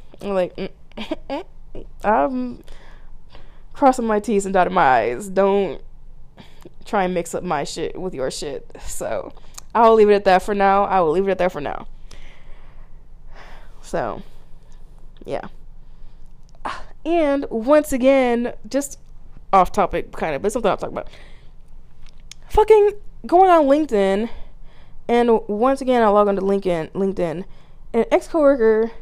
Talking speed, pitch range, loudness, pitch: 140 wpm, 195-275 Hz, -19 LUFS, 220 Hz